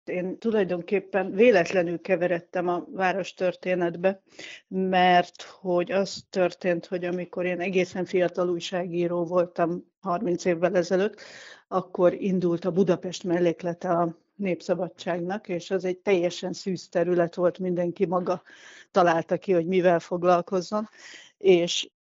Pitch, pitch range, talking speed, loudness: 180 Hz, 175-185 Hz, 115 wpm, -26 LUFS